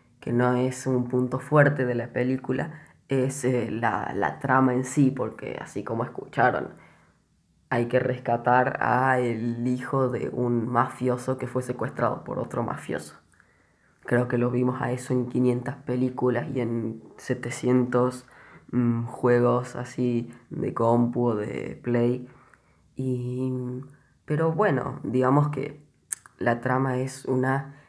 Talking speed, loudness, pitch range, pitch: 135 wpm, -26 LUFS, 120-130 Hz, 125 Hz